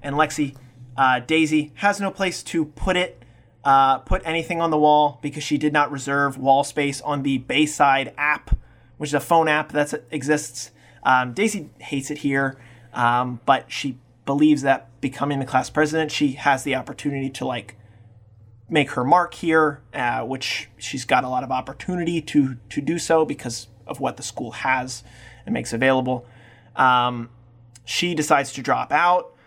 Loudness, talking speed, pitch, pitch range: -22 LUFS, 175 wpm, 135 Hz, 125-150 Hz